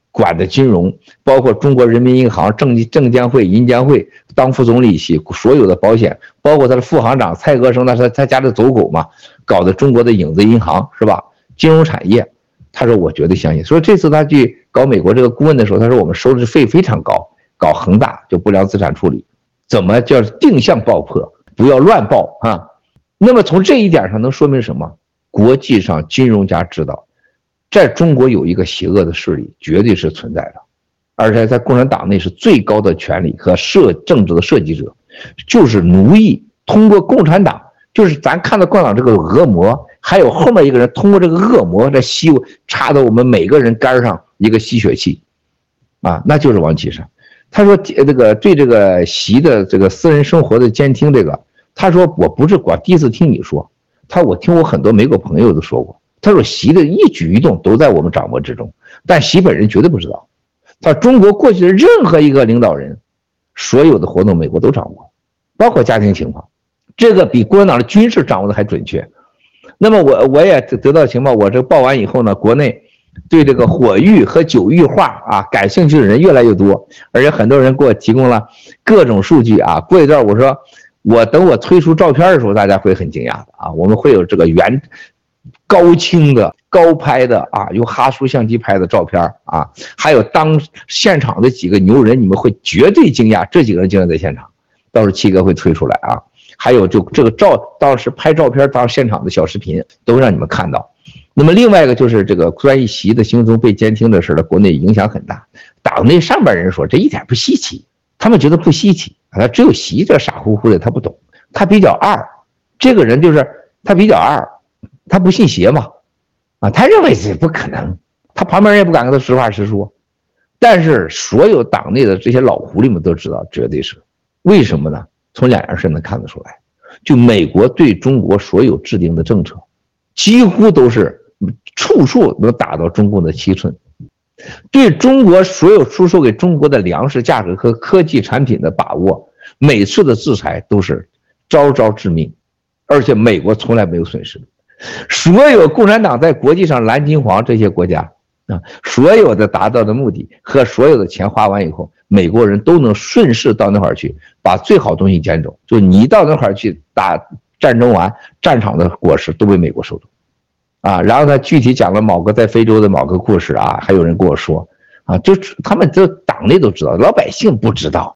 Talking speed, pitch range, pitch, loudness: 295 characters per minute, 105-160 Hz, 125 Hz, -10 LUFS